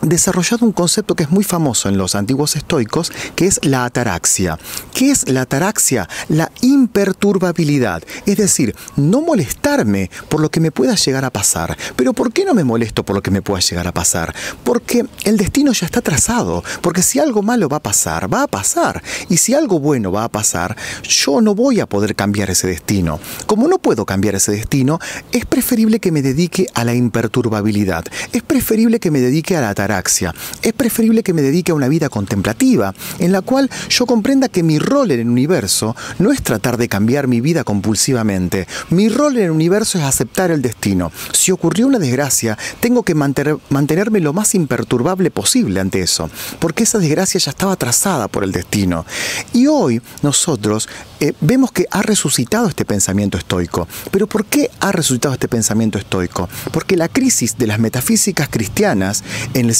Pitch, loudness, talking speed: 145 Hz, -15 LUFS, 190 wpm